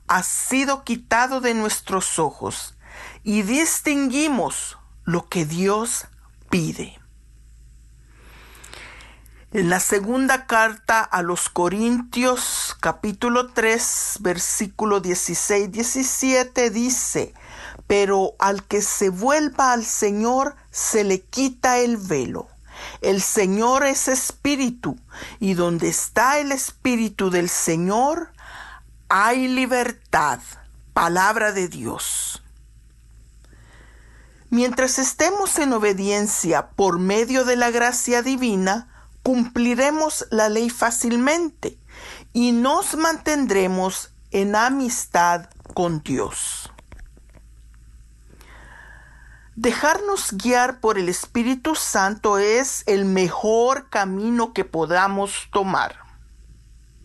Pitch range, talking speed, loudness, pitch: 185-255 Hz, 90 wpm, -20 LUFS, 220 Hz